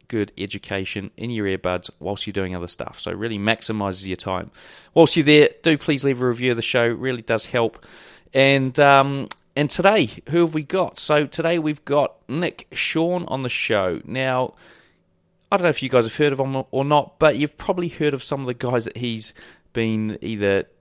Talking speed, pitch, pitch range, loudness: 215 wpm, 130 Hz, 110-150 Hz, -21 LUFS